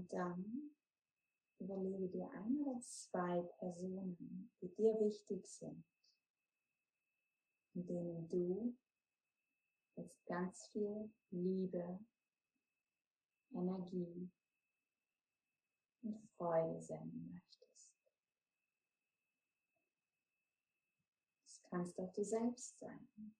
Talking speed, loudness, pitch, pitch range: 75 wpm, -45 LUFS, 190 Hz, 180-220 Hz